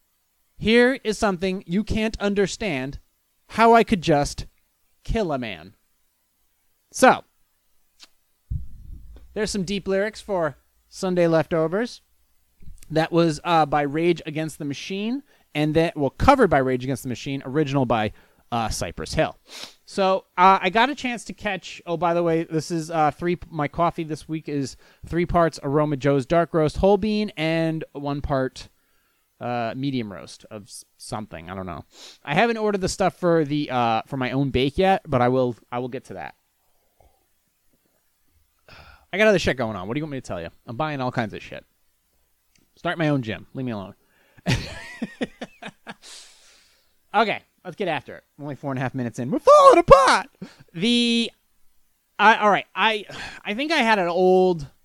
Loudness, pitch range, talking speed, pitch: -22 LUFS, 130-190 Hz, 175 wpm, 160 Hz